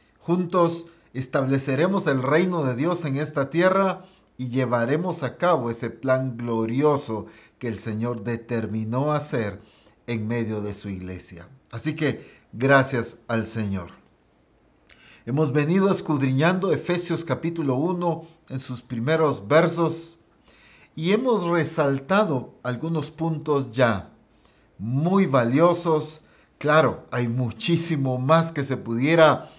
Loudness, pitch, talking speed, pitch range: -23 LUFS, 135 Hz, 115 wpm, 115-165 Hz